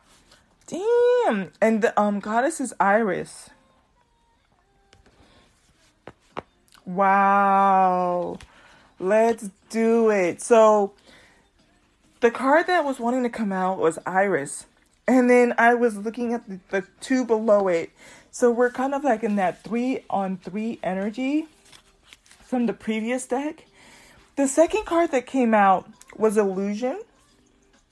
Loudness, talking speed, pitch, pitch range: -22 LUFS, 120 wpm, 225 Hz, 200-255 Hz